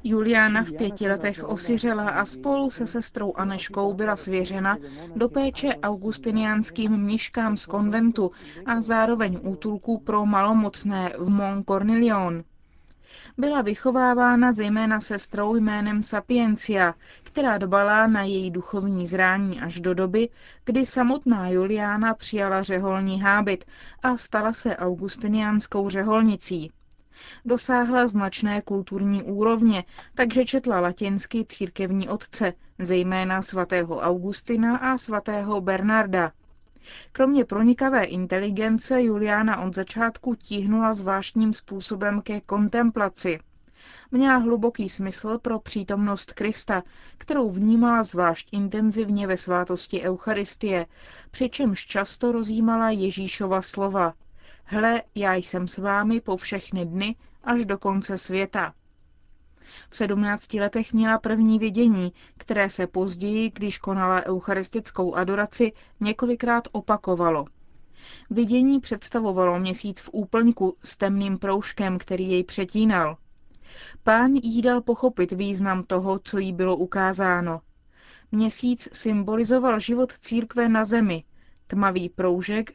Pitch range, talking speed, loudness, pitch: 190-230 Hz, 110 wpm, -24 LUFS, 205 Hz